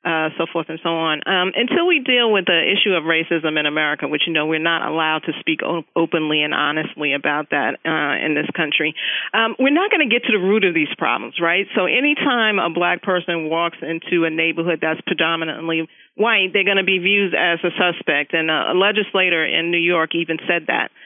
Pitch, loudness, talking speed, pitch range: 170 Hz, -18 LUFS, 220 wpm, 160-195 Hz